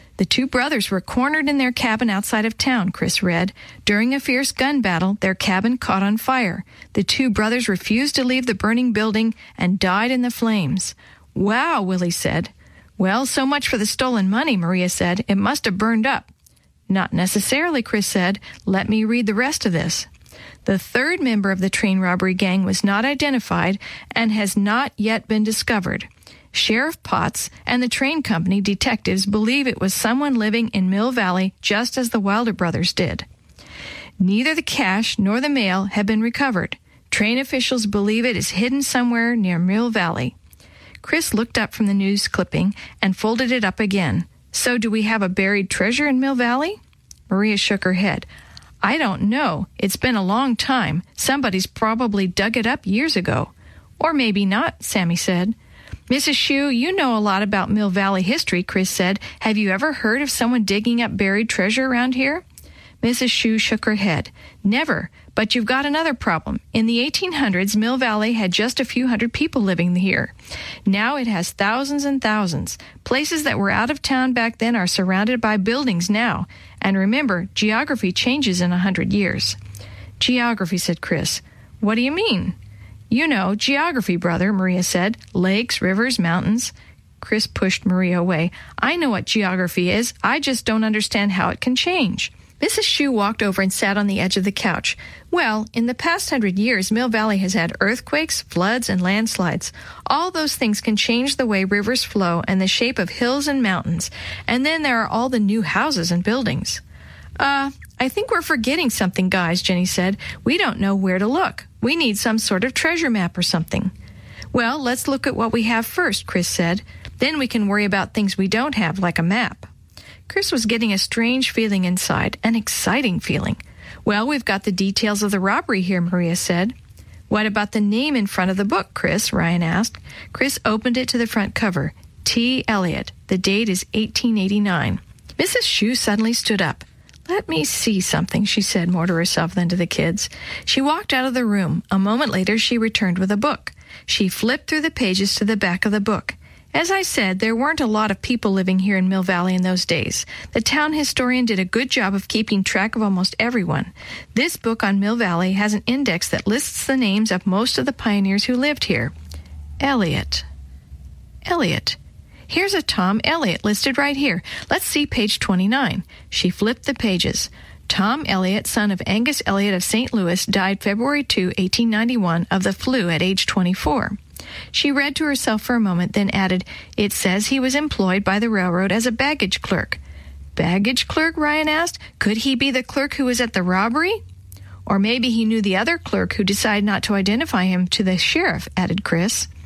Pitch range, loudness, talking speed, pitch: 190-250 Hz, -19 LUFS, 190 wpm, 215 Hz